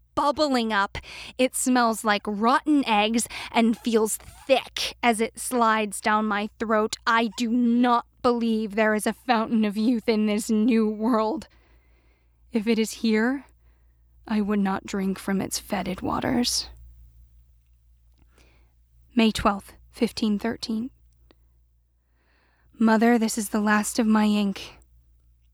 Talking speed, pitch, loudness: 125 wpm, 215 Hz, -24 LUFS